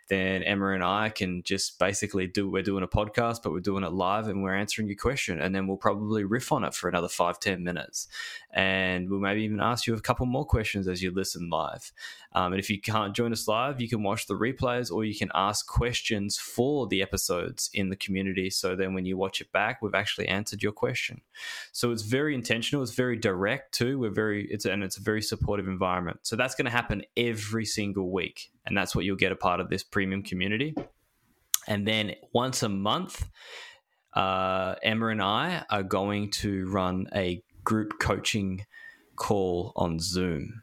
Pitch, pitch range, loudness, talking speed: 100 Hz, 95-110 Hz, -29 LUFS, 205 wpm